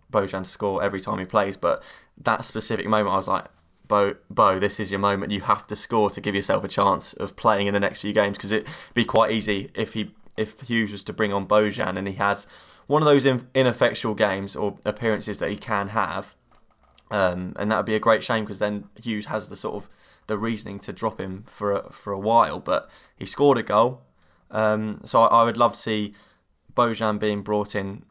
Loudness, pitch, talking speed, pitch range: -24 LUFS, 105 Hz, 225 wpm, 100-110 Hz